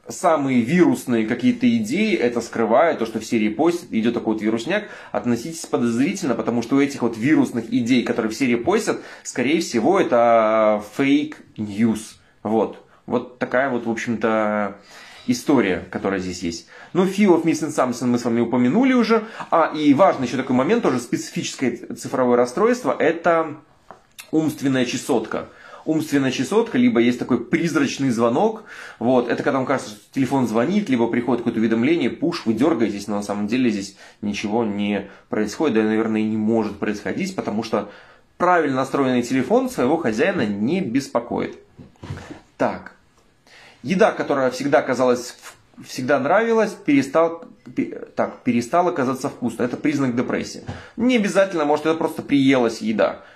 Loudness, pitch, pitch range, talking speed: -20 LUFS, 130 Hz, 115-170 Hz, 150 wpm